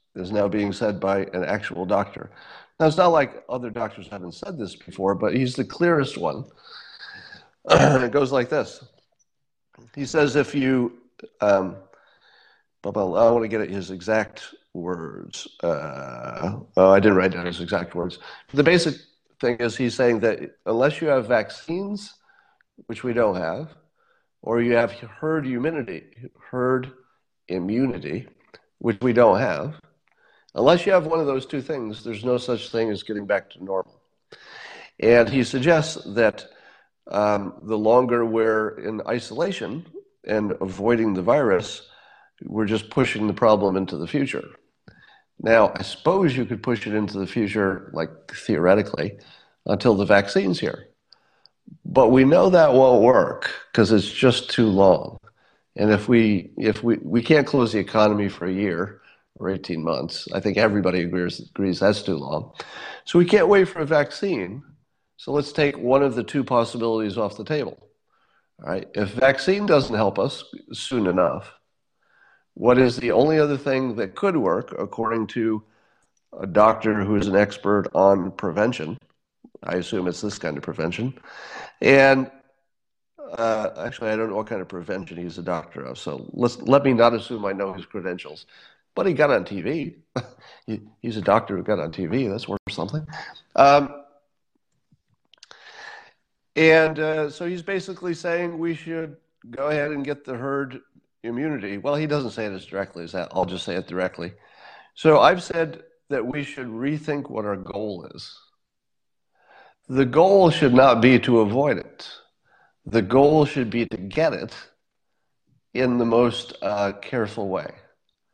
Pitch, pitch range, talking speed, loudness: 120 Hz, 105-140 Hz, 165 wpm, -22 LUFS